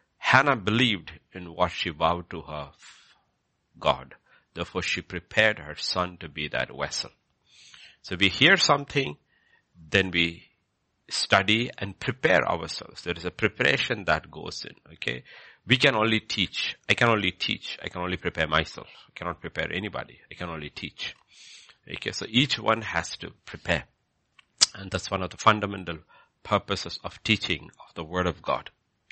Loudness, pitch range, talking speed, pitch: -26 LUFS, 85-110 Hz, 165 wpm, 90 Hz